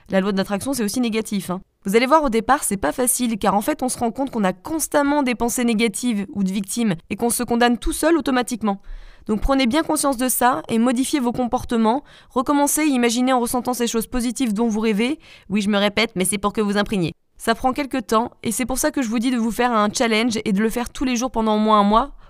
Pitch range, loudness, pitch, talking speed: 215-260 Hz, -20 LUFS, 235 Hz, 265 wpm